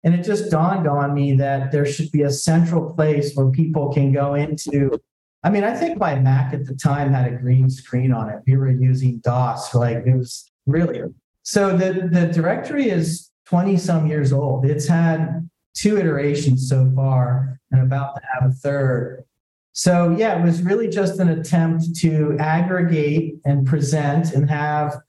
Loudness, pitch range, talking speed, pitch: -19 LUFS, 135-170 Hz, 180 wpm, 150 Hz